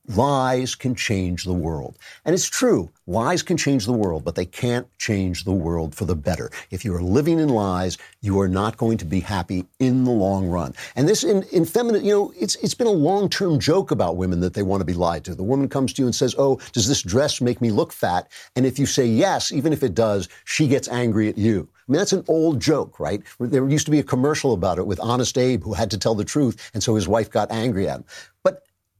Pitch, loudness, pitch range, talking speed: 120 Hz, -21 LUFS, 95-135 Hz, 255 wpm